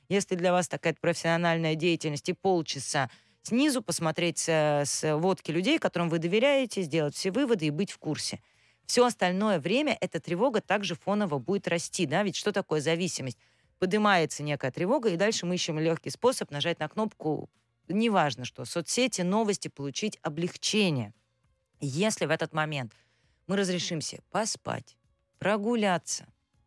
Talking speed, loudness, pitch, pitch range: 140 wpm, -28 LUFS, 170 Hz, 150-200 Hz